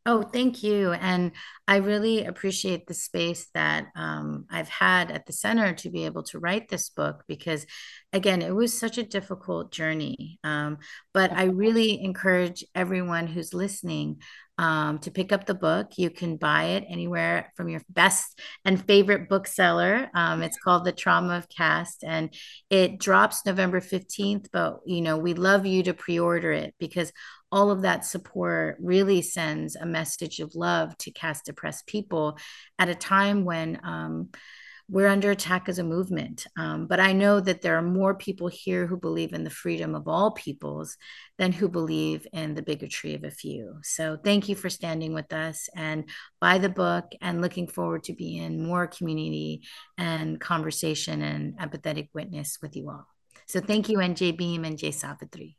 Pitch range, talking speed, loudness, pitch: 155-195 Hz, 180 wpm, -26 LUFS, 175 Hz